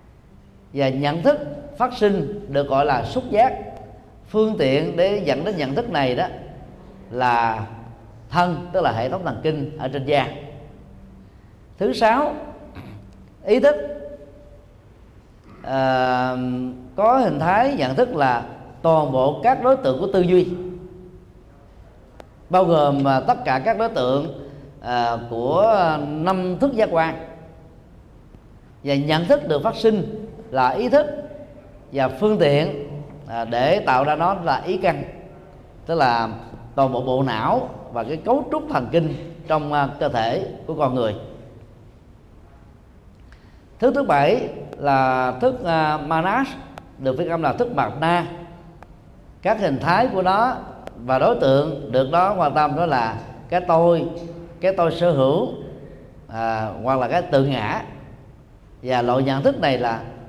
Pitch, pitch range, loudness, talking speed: 145 Hz, 120-180 Hz, -20 LUFS, 145 wpm